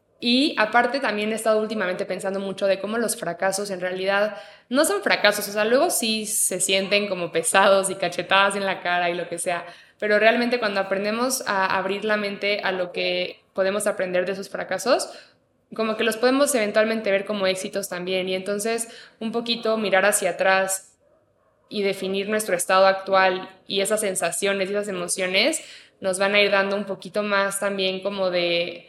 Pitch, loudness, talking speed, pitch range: 195 Hz, -22 LUFS, 185 wpm, 190-215 Hz